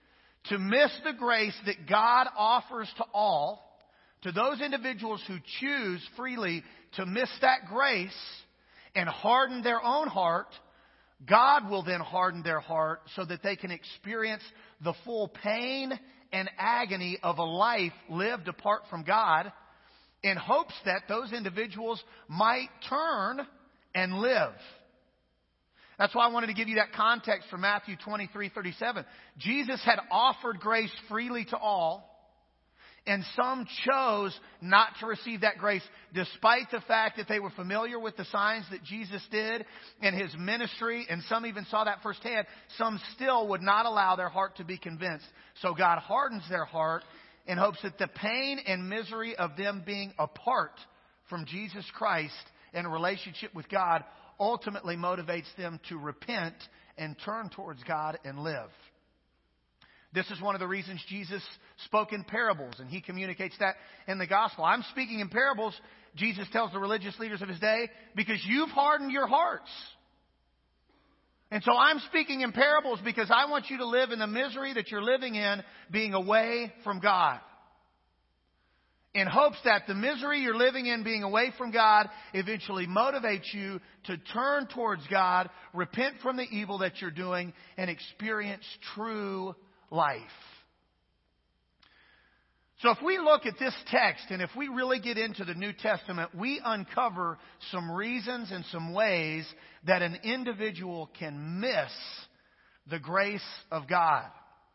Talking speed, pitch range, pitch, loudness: 155 wpm, 180-235 Hz, 205 Hz, -30 LUFS